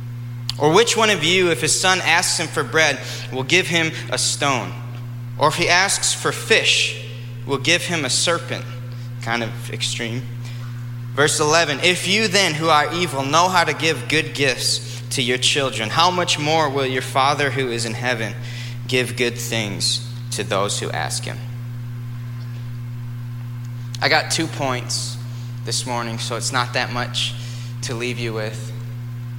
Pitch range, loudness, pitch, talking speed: 120-140 Hz, -19 LUFS, 120 Hz, 165 wpm